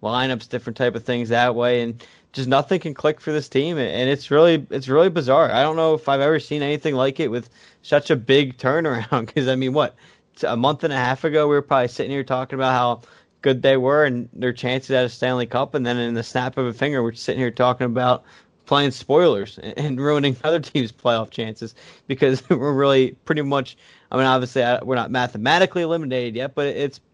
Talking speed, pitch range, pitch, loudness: 220 wpm, 125-145 Hz, 130 Hz, -20 LUFS